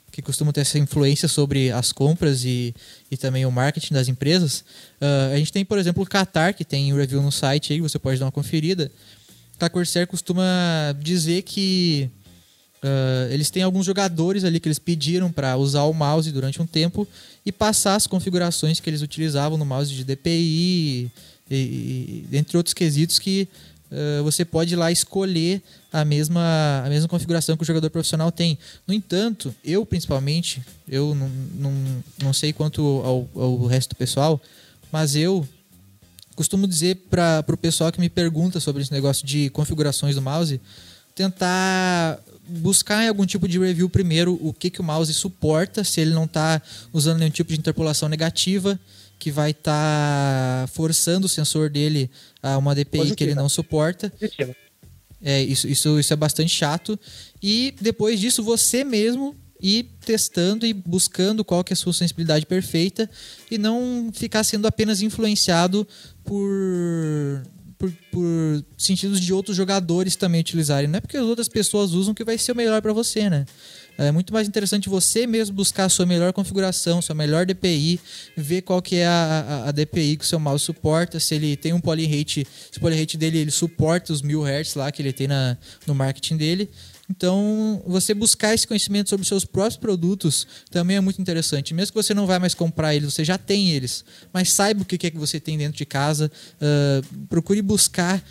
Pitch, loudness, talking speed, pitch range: 165 Hz, -21 LUFS, 185 wpm, 145-185 Hz